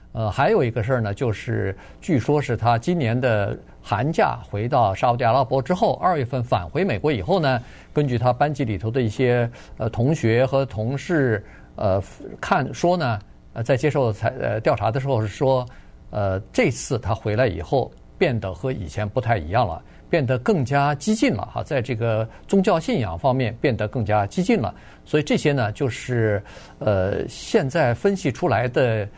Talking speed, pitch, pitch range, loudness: 260 characters per minute, 125 Hz, 110-140 Hz, -22 LUFS